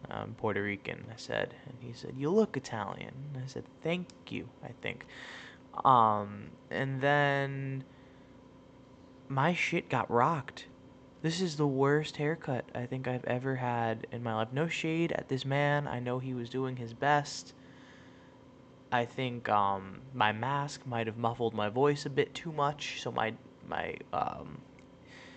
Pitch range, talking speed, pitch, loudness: 120-145 Hz, 165 wpm, 130 Hz, -33 LUFS